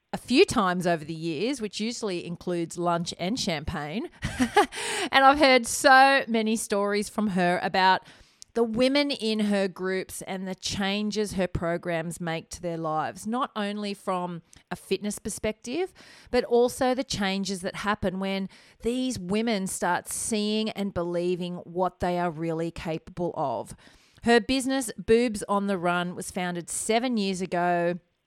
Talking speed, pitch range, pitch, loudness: 150 wpm, 175-230 Hz, 200 Hz, -26 LUFS